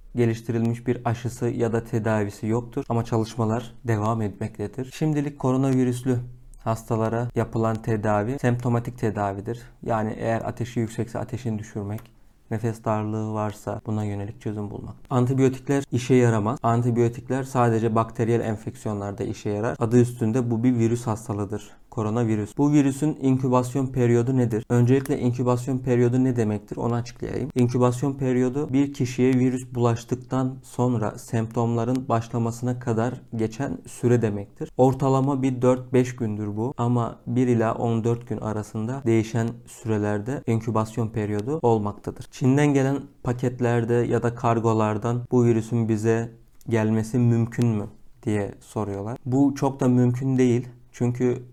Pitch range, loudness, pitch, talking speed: 115-125 Hz, -24 LUFS, 120 Hz, 125 wpm